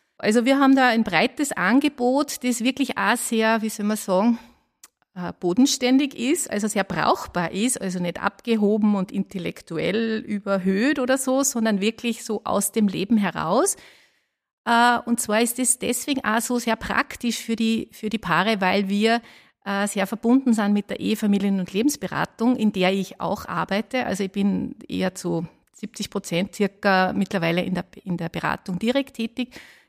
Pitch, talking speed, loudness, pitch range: 220 Hz, 165 wpm, -22 LUFS, 195-245 Hz